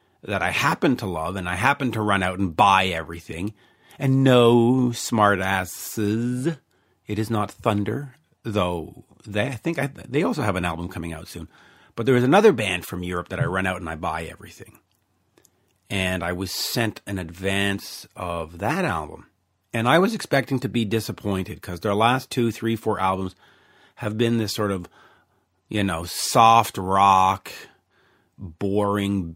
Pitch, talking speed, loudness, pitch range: 100 Hz, 170 wpm, -22 LUFS, 95-115 Hz